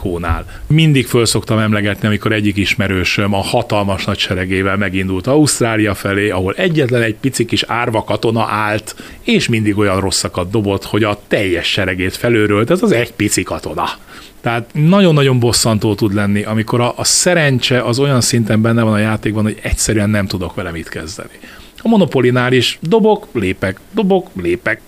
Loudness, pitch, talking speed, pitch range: -14 LUFS, 110 Hz, 165 wpm, 100-125 Hz